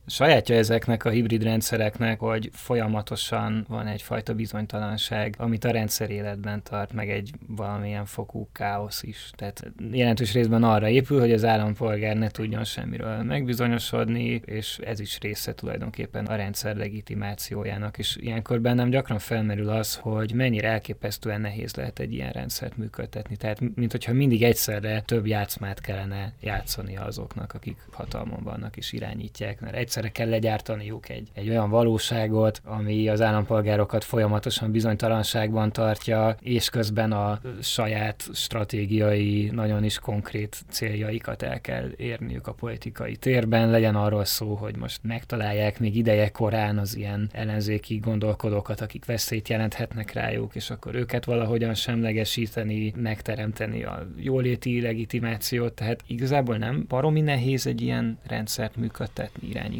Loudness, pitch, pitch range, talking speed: -26 LUFS, 110 Hz, 105-115 Hz, 135 wpm